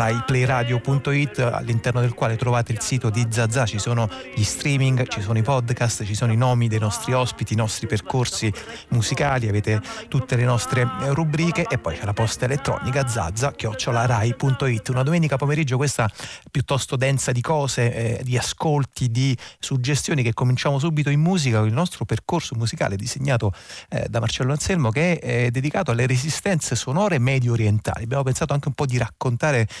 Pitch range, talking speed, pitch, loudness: 115-140 Hz, 170 wpm, 125 Hz, -22 LUFS